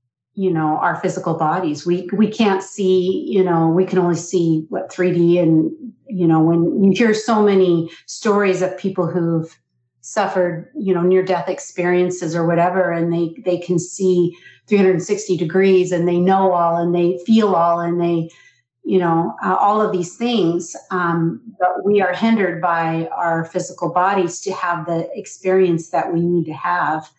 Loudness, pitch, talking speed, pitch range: -18 LUFS, 180 Hz, 175 wpm, 170-190 Hz